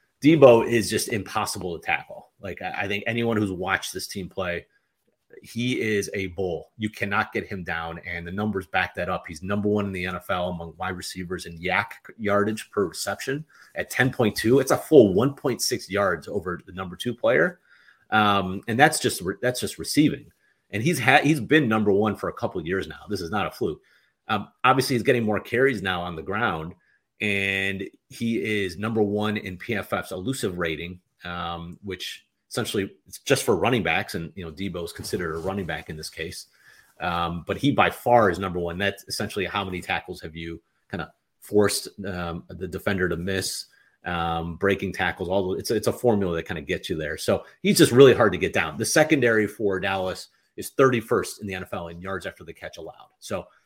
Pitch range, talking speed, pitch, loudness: 90-105 Hz, 205 wpm, 95 Hz, -24 LUFS